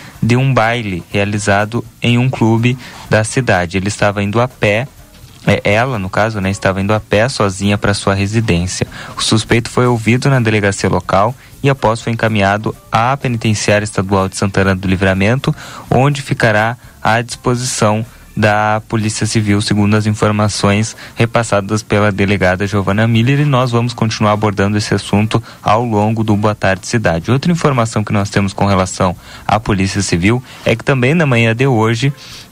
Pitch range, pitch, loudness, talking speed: 100-120 Hz, 110 Hz, -14 LUFS, 165 wpm